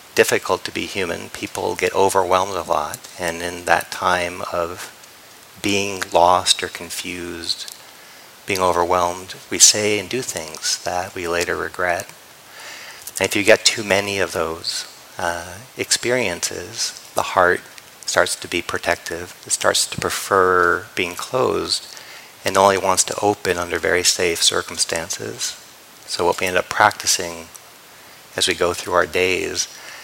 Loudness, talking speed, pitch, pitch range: -19 LUFS, 145 wpm, 95 Hz, 85-100 Hz